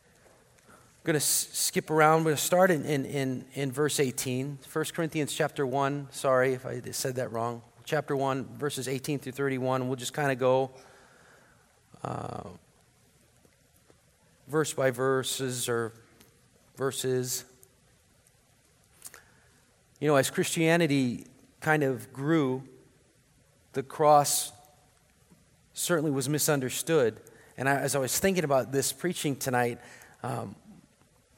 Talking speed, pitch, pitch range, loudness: 120 wpm, 135 Hz, 130-150 Hz, -28 LUFS